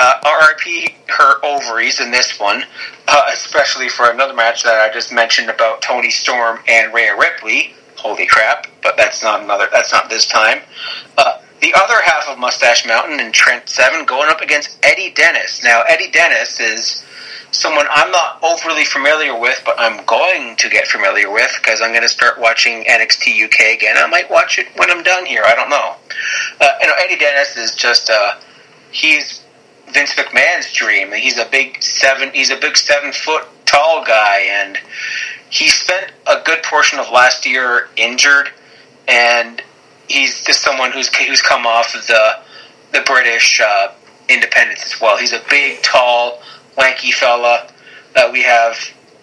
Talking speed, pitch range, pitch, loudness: 175 wpm, 115-145 Hz, 130 Hz, -11 LUFS